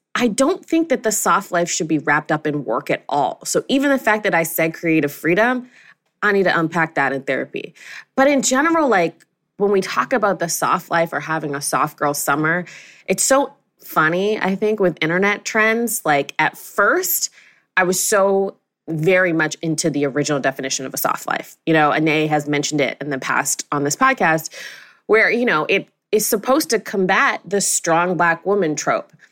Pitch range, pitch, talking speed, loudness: 155-215 Hz, 175 Hz, 200 wpm, -18 LUFS